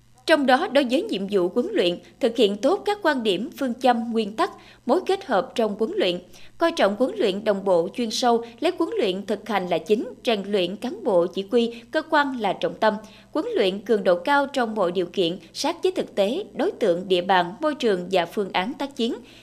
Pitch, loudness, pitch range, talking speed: 230 Hz, -23 LUFS, 195-280 Hz, 230 wpm